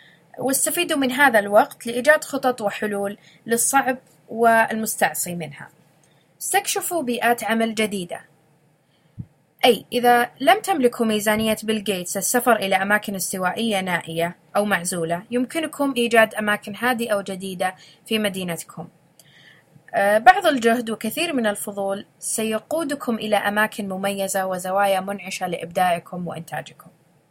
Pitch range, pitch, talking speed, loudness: 175-240 Hz, 205 Hz, 105 wpm, -21 LUFS